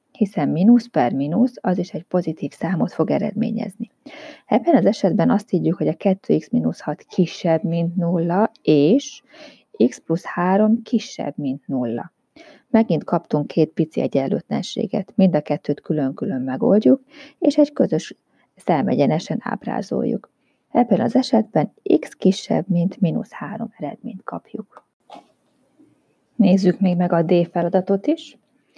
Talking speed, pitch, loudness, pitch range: 125 wpm, 195 Hz, -20 LUFS, 170-250 Hz